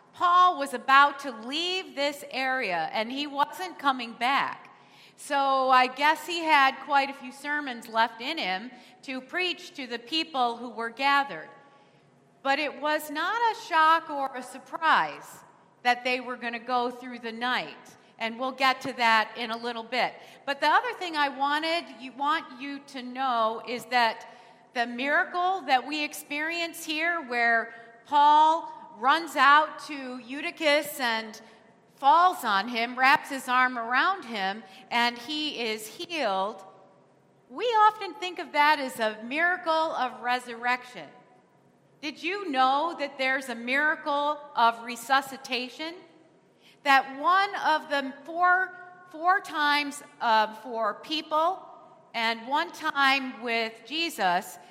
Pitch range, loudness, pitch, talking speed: 240-310 Hz, -26 LUFS, 275 Hz, 145 wpm